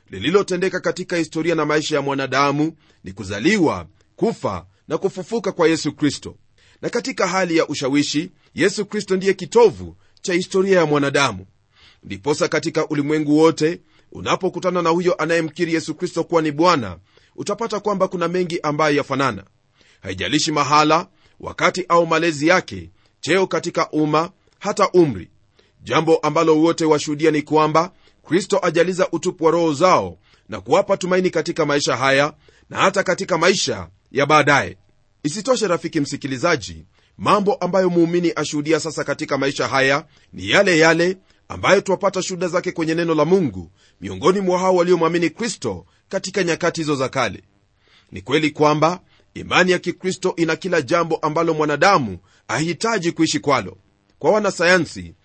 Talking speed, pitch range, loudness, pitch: 140 wpm, 140-180 Hz, -19 LUFS, 160 Hz